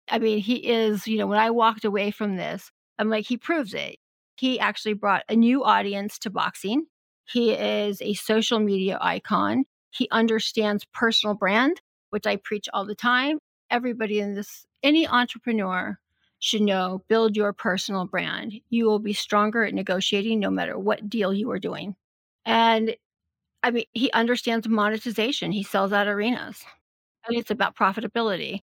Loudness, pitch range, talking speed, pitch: -24 LUFS, 205-235 Hz, 165 wpm, 220 Hz